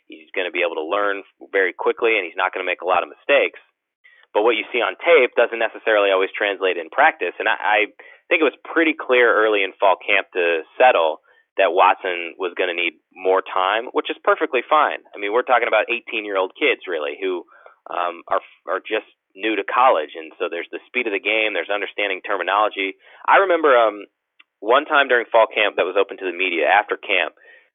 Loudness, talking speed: -19 LUFS, 220 wpm